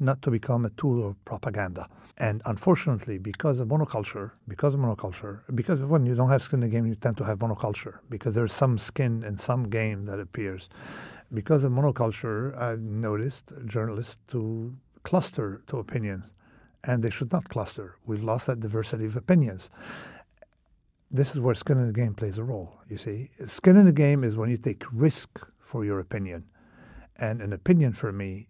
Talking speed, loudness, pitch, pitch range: 185 wpm, -27 LUFS, 115 Hz, 105-135 Hz